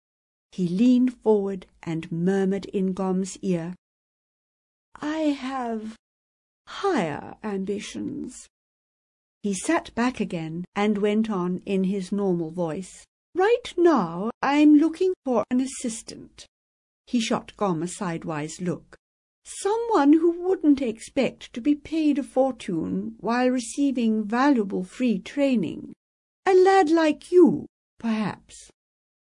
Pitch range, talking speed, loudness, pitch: 195-285 Hz, 115 wpm, -24 LUFS, 225 Hz